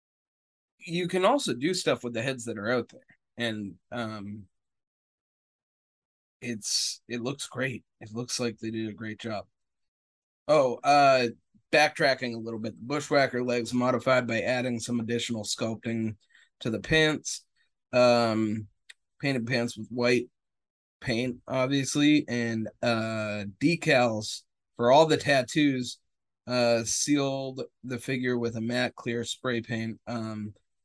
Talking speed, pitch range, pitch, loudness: 135 wpm, 110-130 Hz, 120 Hz, -27 LUFS